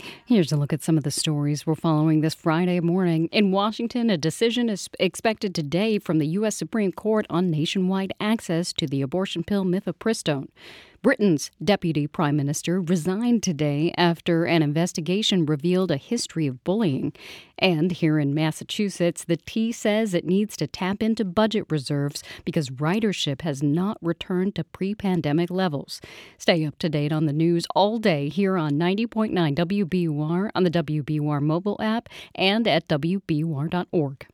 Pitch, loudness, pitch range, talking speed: 175 Hz, -24 LUFS, 155-200 Hz, 160 wpm